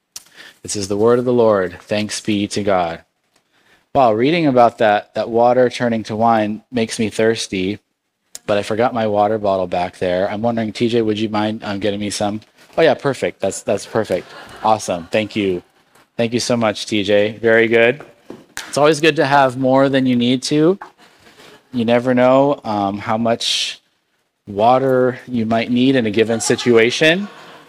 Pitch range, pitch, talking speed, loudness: 105-125 Hz, 115 Hz, 180 wpm, -16 LUFS